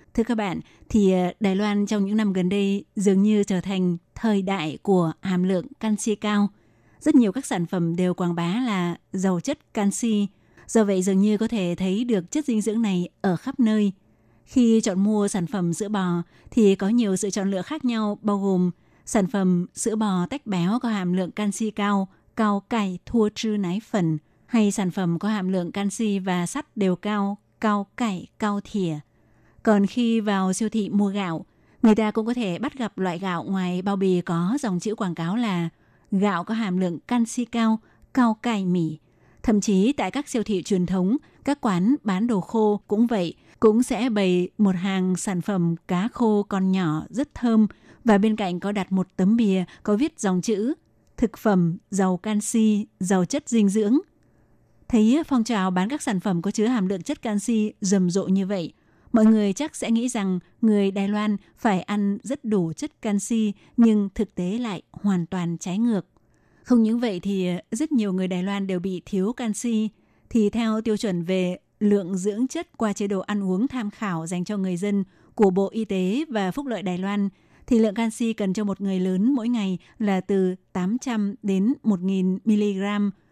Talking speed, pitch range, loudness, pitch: 200 wpm, 185-225 Hz, -24 LUFS, 205 Hz